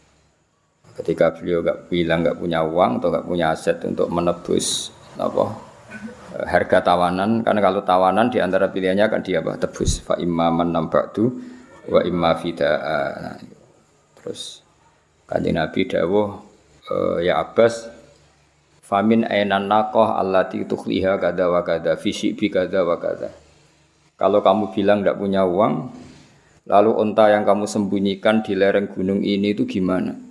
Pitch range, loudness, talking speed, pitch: 95-105 Hz, -20 LUFS, 135 wpm, 100 Hz